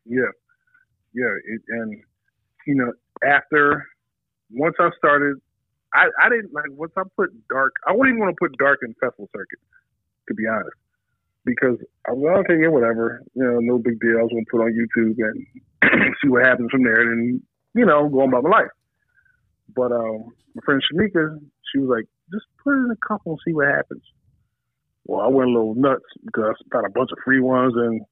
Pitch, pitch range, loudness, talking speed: 130 Hz, 120-160 Hz, -20 LUFS, 205 wpm